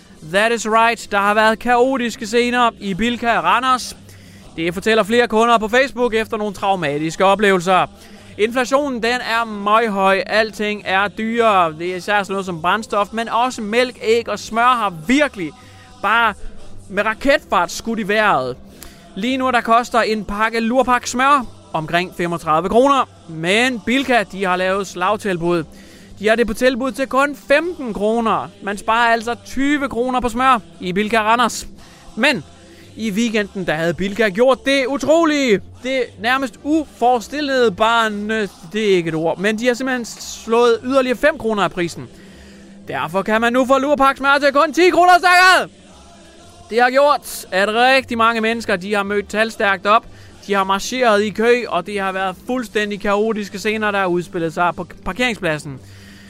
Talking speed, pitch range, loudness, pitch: 165 wpm, 195-245 Hz, -17 LUFS, 220 Hz